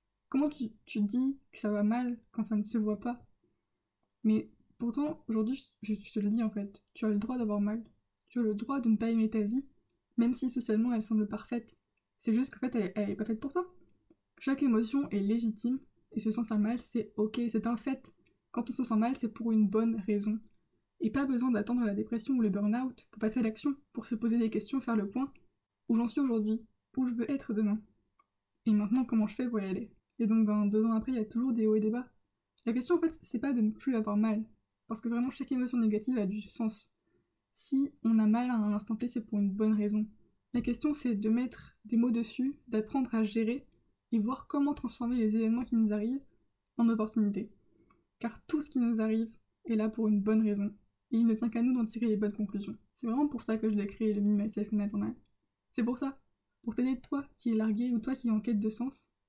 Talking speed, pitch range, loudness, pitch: 245 wpm, 215-250 Hz, -33 LUFS, 230 Hz